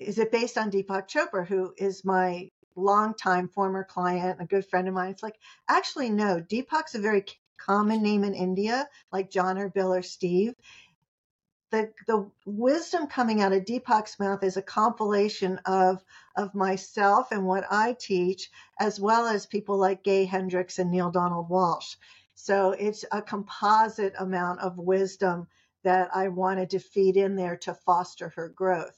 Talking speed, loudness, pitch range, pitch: 170 wpm, -27 LUFS, 185-210 Hz, 195 Hz